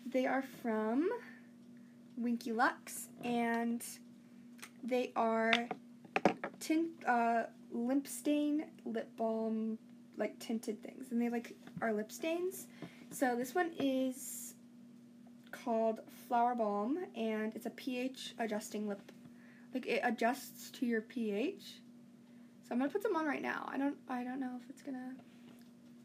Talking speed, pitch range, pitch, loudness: 135 wpm, 230-255 Hz, 240 Hz, -38 LUFS